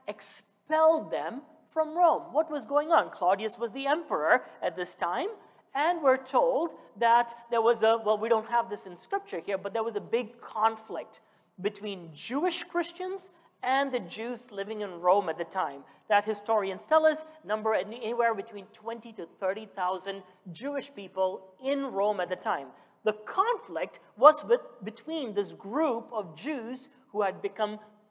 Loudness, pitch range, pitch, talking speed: -29 LUFS, 200-280 Hz, 225 Hz, 165 wpm